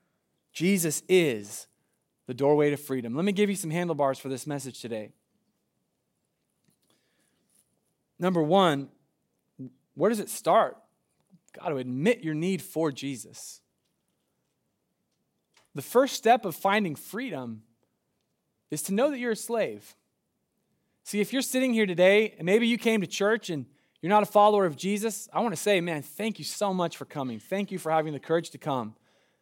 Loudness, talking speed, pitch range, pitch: -27 LUFS, 165 wpm, 140-205 Hz, 175 Hz